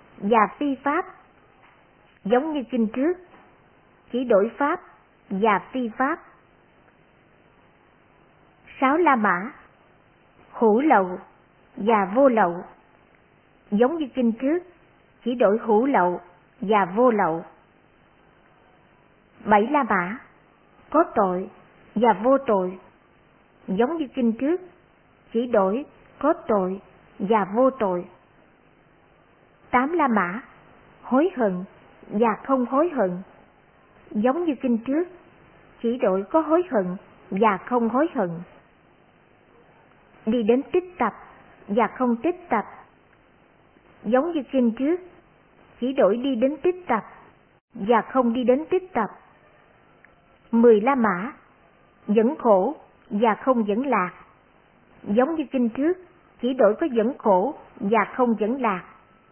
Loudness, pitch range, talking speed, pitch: -23 LUFS, 210-275 Hz, 120 wpm, 240 Hz